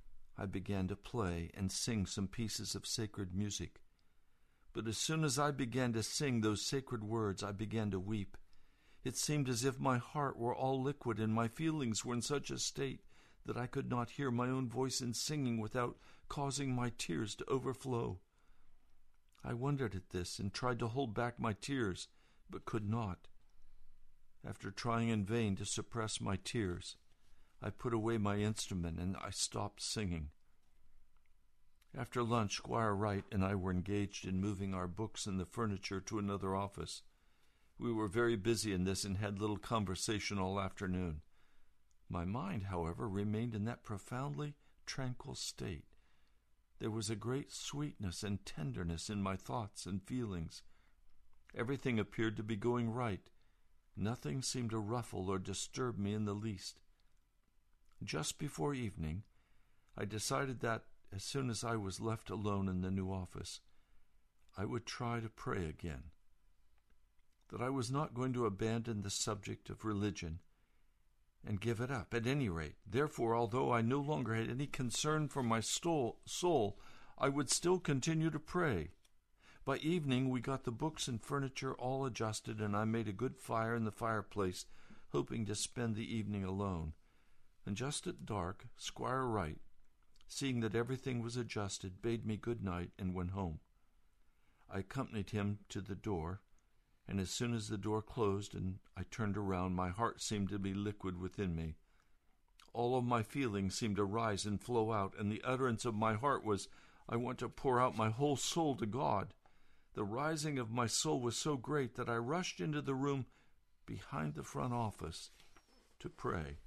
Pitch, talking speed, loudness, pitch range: 110 Hz, 170 wpm, -40 LUFS, 95-125 Hz